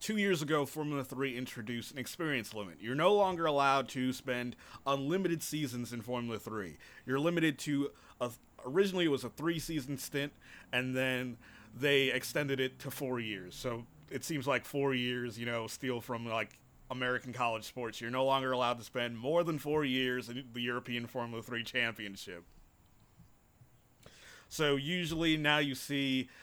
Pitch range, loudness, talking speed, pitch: 120-145 Hz, -35 LUFS, 170 wpm, 130 Hz